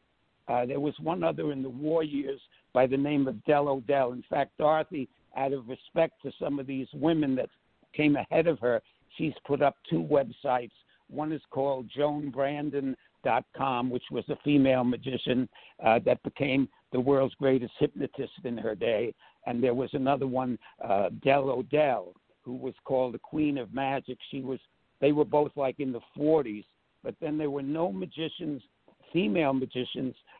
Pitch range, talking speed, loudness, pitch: 130-150 Hz, 170 wpm, -29 LUFS, 140 Hz